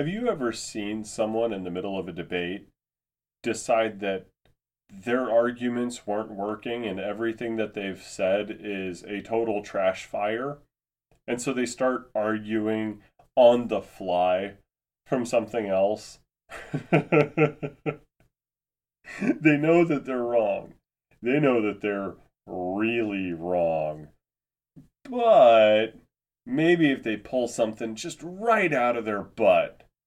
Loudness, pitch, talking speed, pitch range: -26 LUFS, 110 Hz, 120 wpm, 100-130 Hz